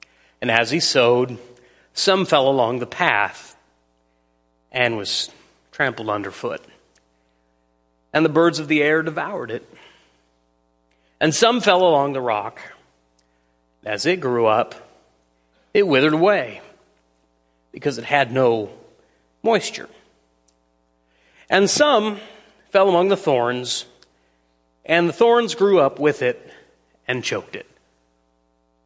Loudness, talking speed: -19 LUFS, 115 wpm